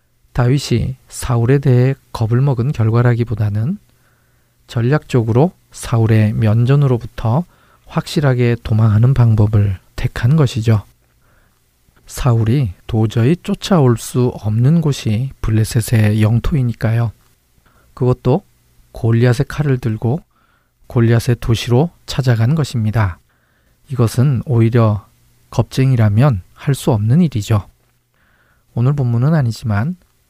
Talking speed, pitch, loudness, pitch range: 250 characters per minute, 120 Hz, -16 LUFS, 110-130 Hz